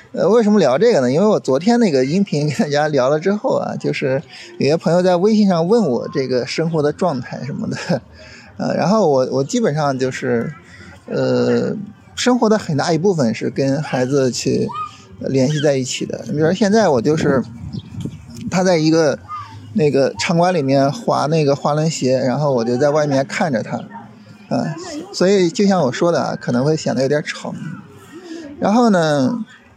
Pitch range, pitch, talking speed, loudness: 135-210 Hz, 160 Hz, 260 characters per minute, -17 LUFS